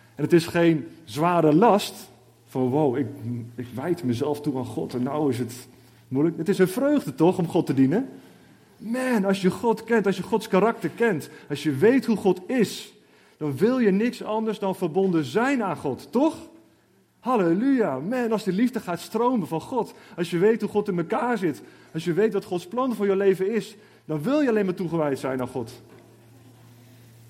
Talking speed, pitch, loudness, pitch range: 200 wpm, 180 Hz, -24 LUFS, 145-220 Hz